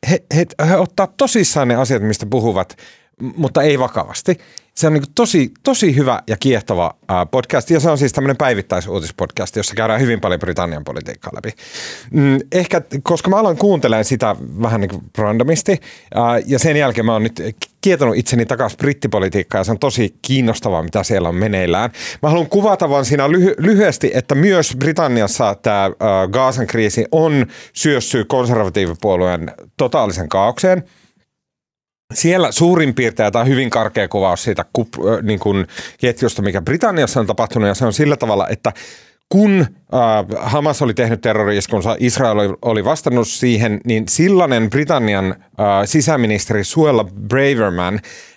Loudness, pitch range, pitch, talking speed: -15 LUFS, 110-155 Hz, 125 Hz, 150 wpm